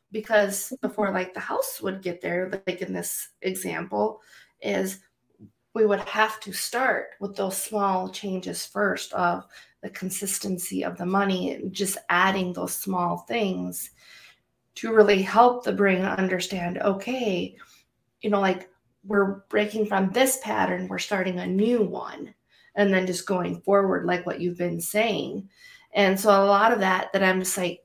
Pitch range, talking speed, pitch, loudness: 185-205 Hz, 160 wpm, 195 Hz, -25 LUFS